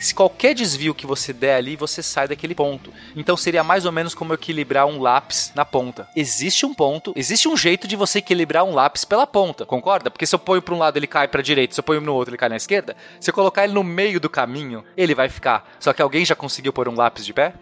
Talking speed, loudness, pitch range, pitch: 265 wpm, -19 LUFS, 140-185 Hz, 160 Hz